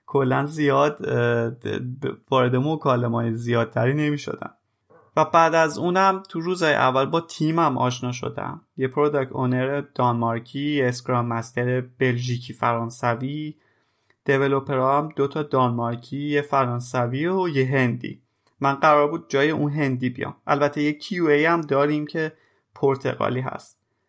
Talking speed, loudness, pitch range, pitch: 130 wpm, -23 LUFS, 125-150 Hz, 140 Hz